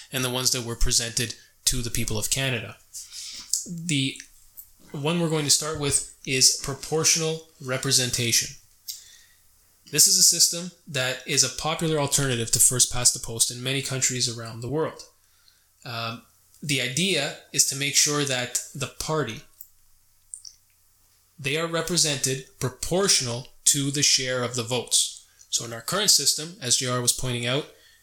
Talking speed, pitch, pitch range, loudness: 145 wpm, 130 Hz, 115-150 Hz, -22 LUFS